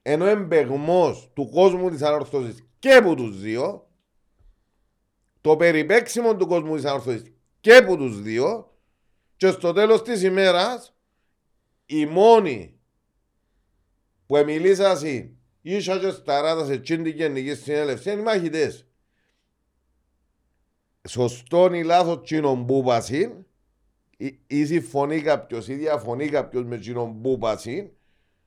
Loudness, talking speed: -21 LUFS, 120 wpm